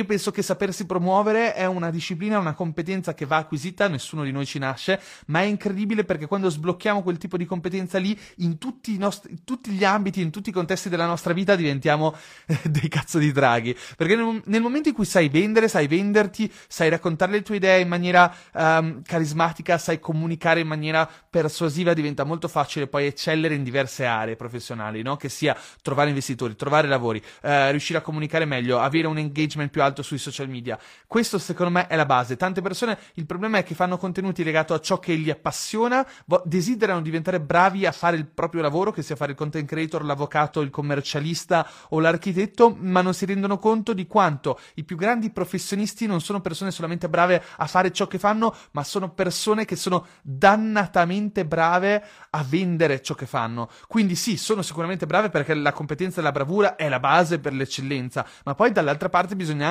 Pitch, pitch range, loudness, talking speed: 170 Hz, 155-195 Hz, -23 LUFS, 195 wpm